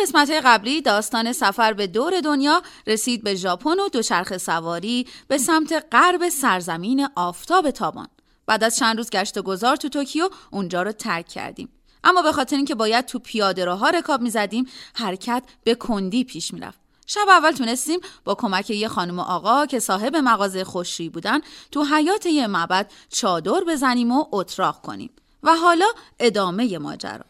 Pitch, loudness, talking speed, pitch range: 240 Hz, -21 LUFS, 165 wpm, 200-300 Hz